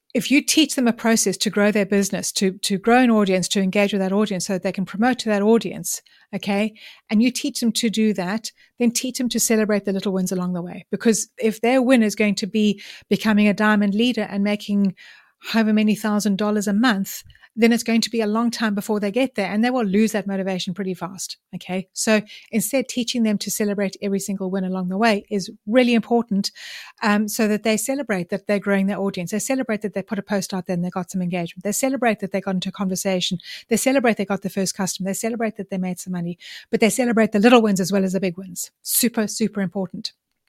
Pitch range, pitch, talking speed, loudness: 195-230 Hz, 210 Hz, 245 wpm, -21 LUFS